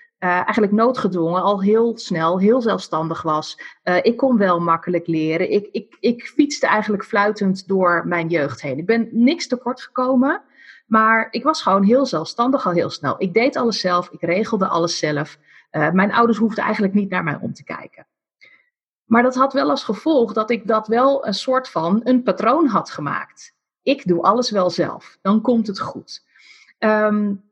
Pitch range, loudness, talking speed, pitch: 180-240 Hz, -19 LUFS, 185 wpm, 215 Hz